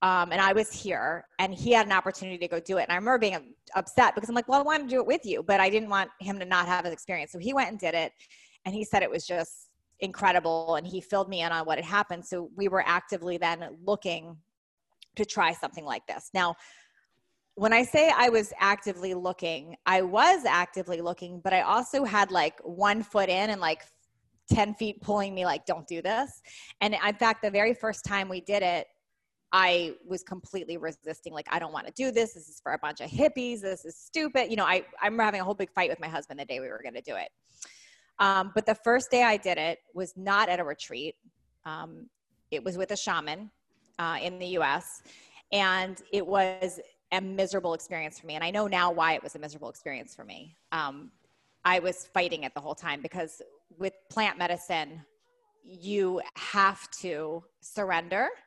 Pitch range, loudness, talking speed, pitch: 175-205 Hz, -28 LUFS, 215 wpm, 185 Hz